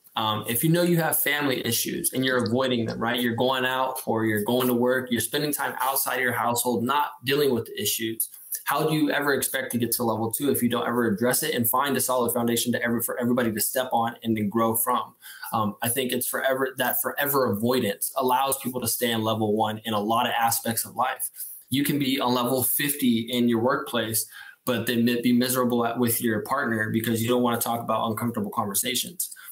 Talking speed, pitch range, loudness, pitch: 230 wpm, 115-130 Hz, -24 LUFS, 120 Hz